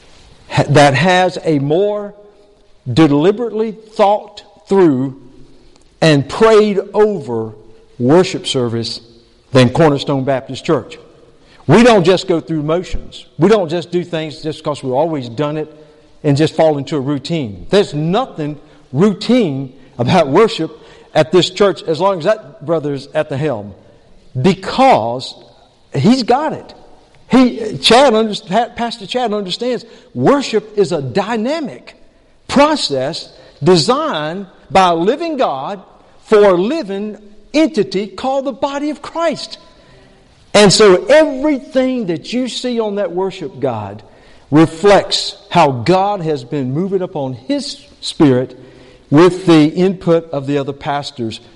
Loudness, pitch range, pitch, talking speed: -14 LUFS, 145-210 Hz, 175 Hz, 125 wpm